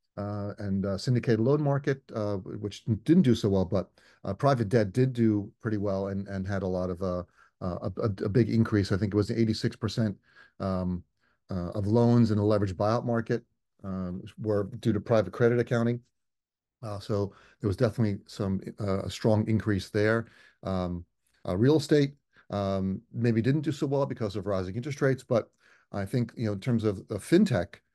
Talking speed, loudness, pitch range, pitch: 190 wpm, -28 LUFS, 100-120 Hz, 105 Hz